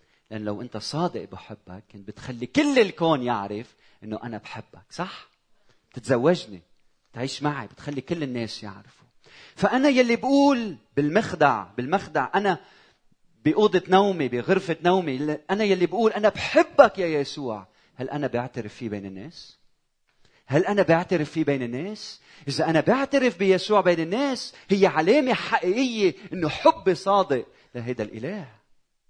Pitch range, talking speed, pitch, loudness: 125-200 Hz, 135 wpm, 160 Hz, -23 LUFS